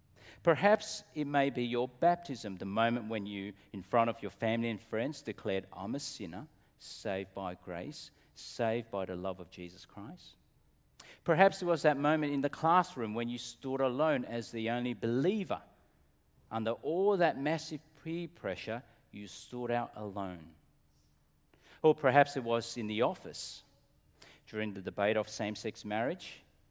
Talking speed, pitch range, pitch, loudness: 155 wpm, 100-145 Hz, 115 Hz, -34 LUFS